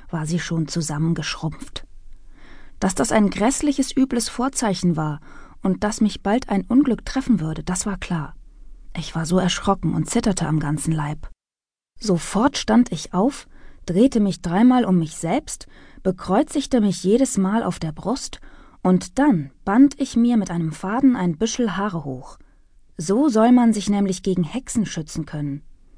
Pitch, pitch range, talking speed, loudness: 195 Hz, 165-235 Hz, 160 wpm, -21 LUFS